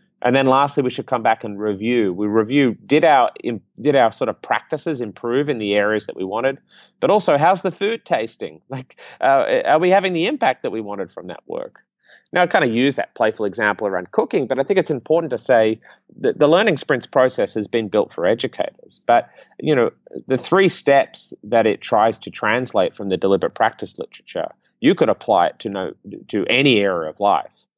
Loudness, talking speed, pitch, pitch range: -19 LUFS, 210 wpm, 130 Hz, 110-165 Hz